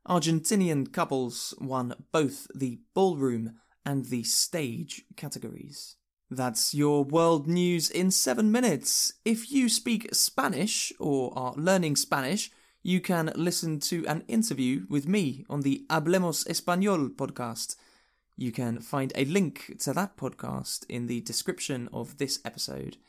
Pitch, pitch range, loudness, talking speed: 150 Hz, 130-185 Hz, -28 LUFS, 135 wpm